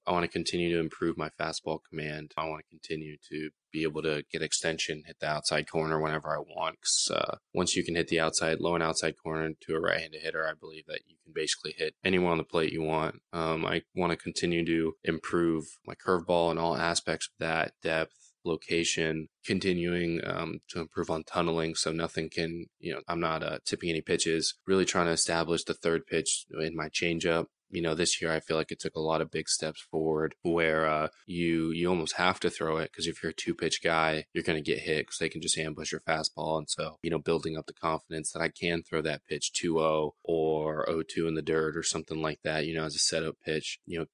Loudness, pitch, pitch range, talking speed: -31 LUFS, 80 Hz, 80-85 Hz, 240 wpm